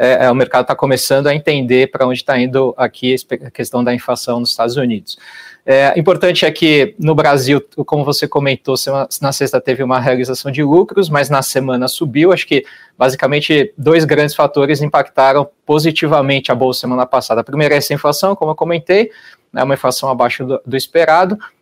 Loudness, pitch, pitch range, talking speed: -13 LUFS, 140 Hz, 130-150 Hz, 185 wpm